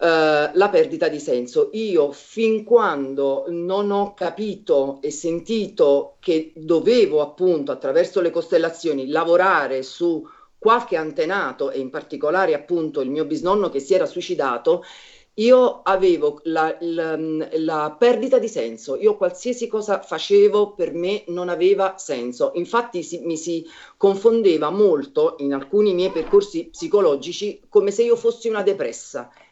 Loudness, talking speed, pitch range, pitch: -20 LUFS, 140 wpm, 160-230 Hz, 185 Hz